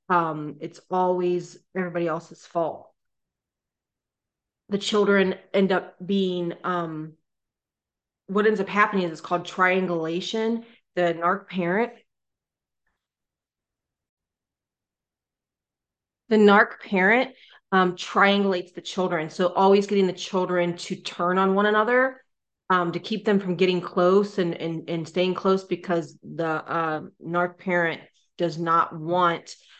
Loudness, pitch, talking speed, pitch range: -24 LUFS, 180 Hz, 120 wpm, 170-195 Hz